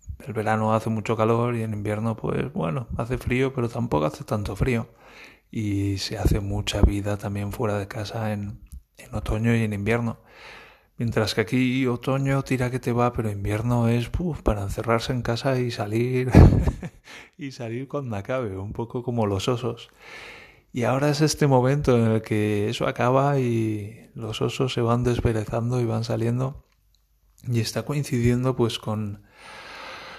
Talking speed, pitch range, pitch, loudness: 165 wpm, 105-125 Hz, 115 Hz, -24 LUFS